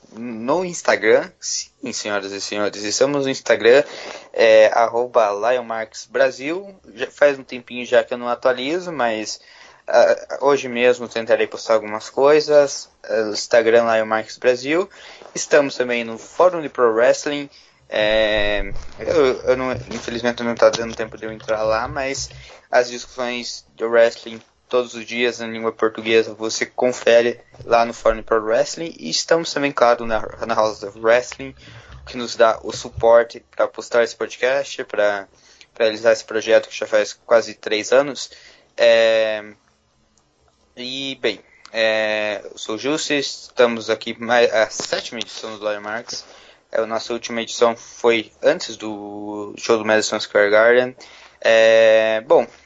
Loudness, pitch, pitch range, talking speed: -19 LUFS, 115 Hz, 110-125 Hz, 145 wpm